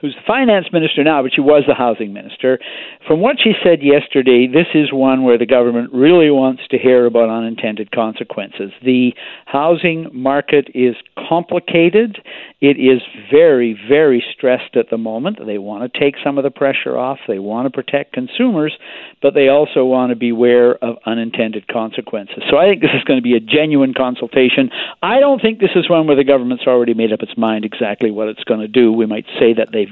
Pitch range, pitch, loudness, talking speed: 120-150 Hz, 130 Hz, -14 LUFS, 205 wpm